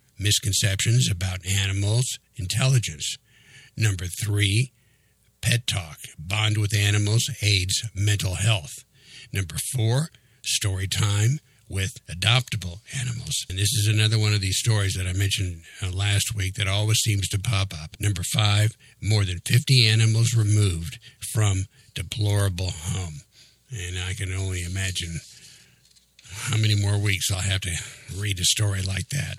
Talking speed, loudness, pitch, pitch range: 135 wpm, -24 LUFS, 105 Hz, 95-115 Hz